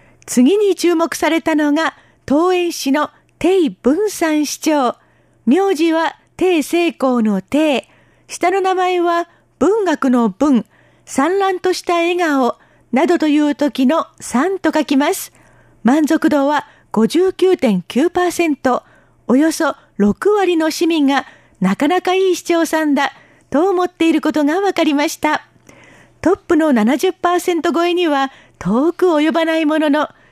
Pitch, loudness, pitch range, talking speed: 320 Hz, -16 LUFS, 285-350 Hz, 215 characters per minute